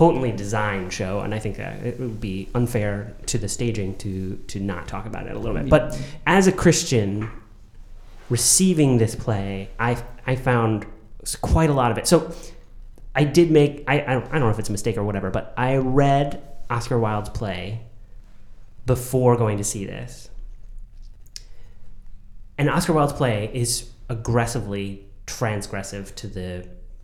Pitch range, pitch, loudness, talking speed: 100-125 Hz, 110 Hz, -22 LUFS, 160 wpm